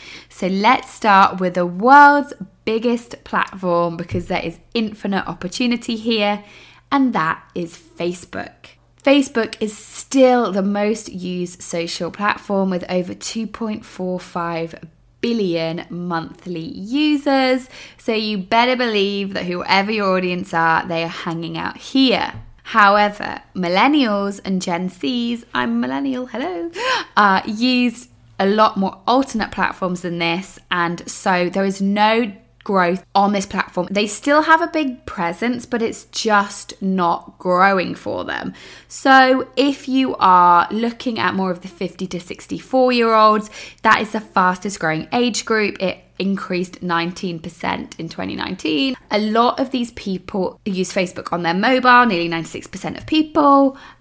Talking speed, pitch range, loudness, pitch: 140 wpm, 180-240 Hz, -18 LUFS, 200 Hz